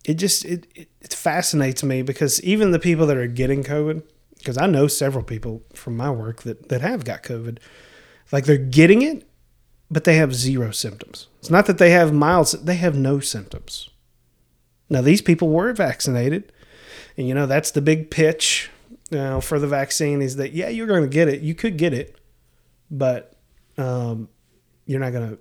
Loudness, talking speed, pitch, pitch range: -19 LUFS, 190 wpm, 145 Hz, 125-165 Hz